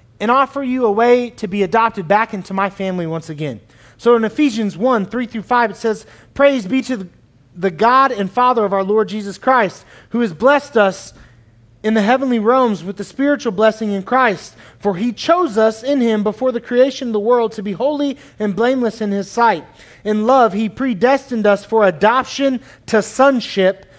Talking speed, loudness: 195 wpm, -16 LUFS